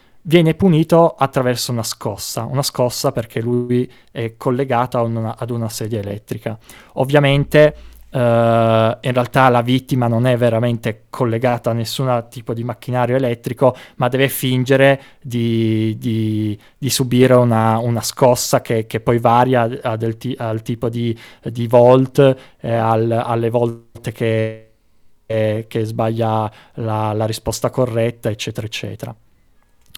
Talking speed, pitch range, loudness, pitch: 135 wpm, 115-130 Hz, -17 LUFS, 120 Hz